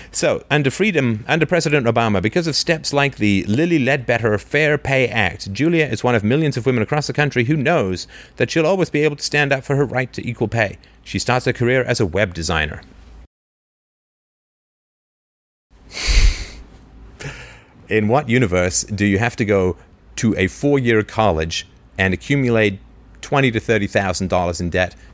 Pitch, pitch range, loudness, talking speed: 115 Hz, 95-140 Hz, -18 LUFS, 165 wpm